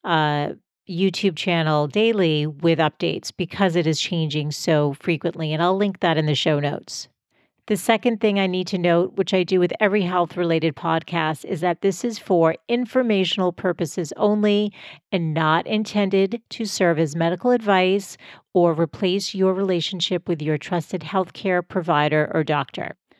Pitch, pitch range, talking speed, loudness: 180 Hz, 165-195 Hz, 160 wpm, -21 LUFS